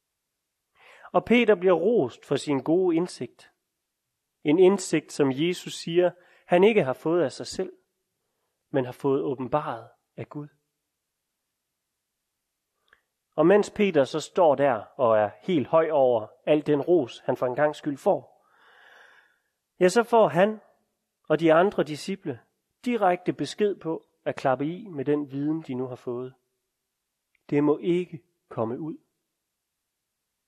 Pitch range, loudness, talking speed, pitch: 135-180 Hz, -25 LUFS, 140 wpm, 155 Hz